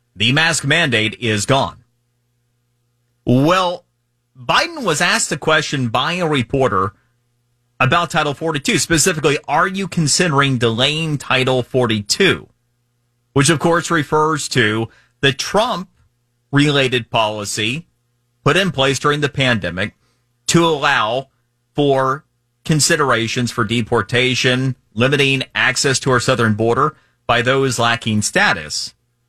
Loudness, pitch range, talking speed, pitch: -16 LUFS, 120-145 Hz, 115 wpm, 125 Hz